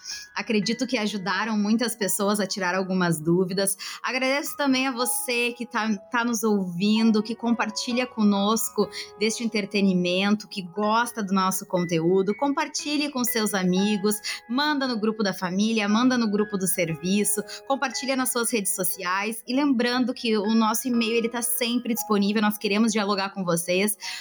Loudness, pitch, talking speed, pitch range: -24 LUFS, 215 Hz, 150 wpm, 200-240 Hz